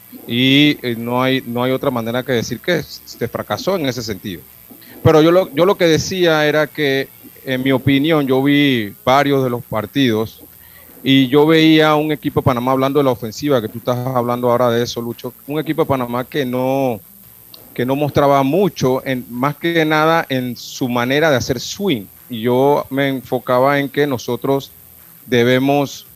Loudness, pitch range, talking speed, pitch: -16 LUFS, 125-145 Hz, 185 wpm, 135 Hz